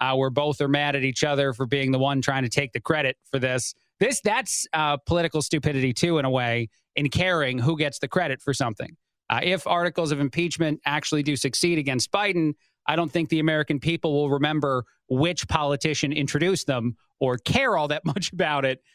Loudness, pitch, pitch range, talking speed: -24 LUFS, 145 Hz, 135-160 Hz, 205 wpm